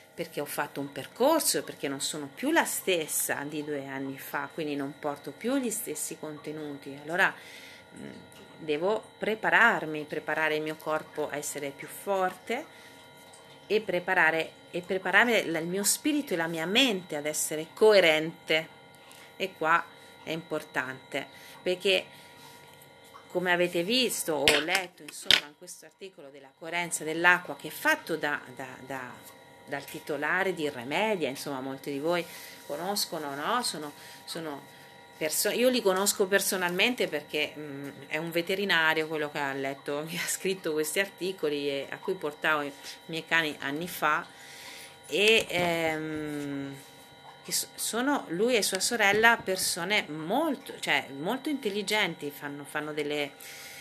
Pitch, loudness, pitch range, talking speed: 160 Hz, -28 LUFS, 150-190 Hz, 140 wpm